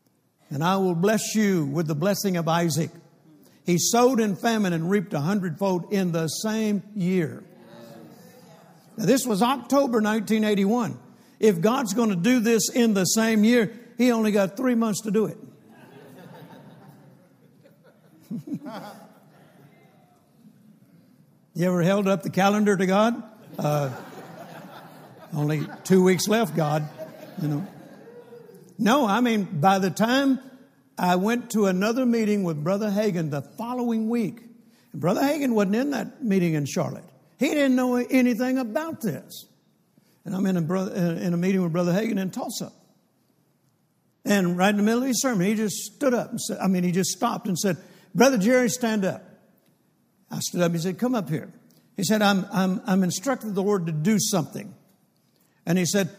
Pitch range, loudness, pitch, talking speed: 180-230 Hz, -24 LUFS, 205 Hz, 165 wpm